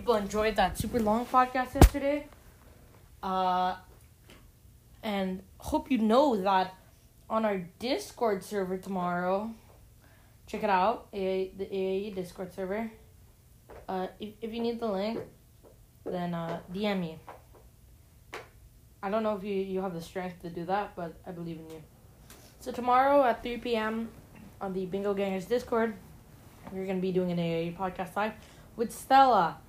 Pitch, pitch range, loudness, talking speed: 195 Hz, 185-225 Hz, -30 LUFS, 150 wpm